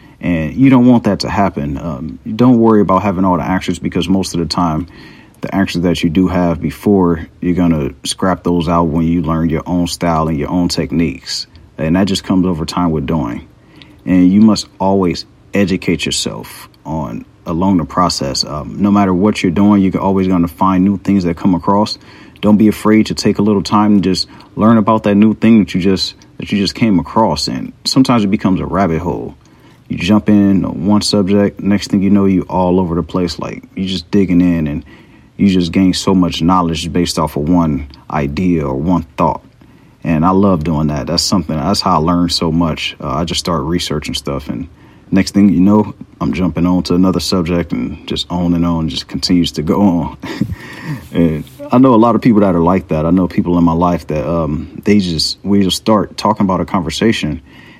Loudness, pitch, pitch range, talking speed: -13 LUFS, 90 Hz, 85-100 Hz, 215 wpm